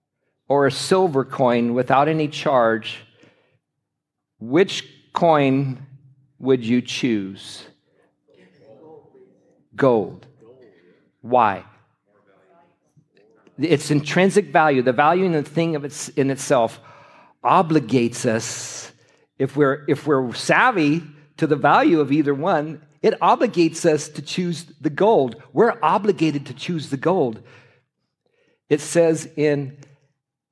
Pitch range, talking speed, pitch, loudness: 130-155 Hz, 110 wpm, 145 Hz, -20 LUFS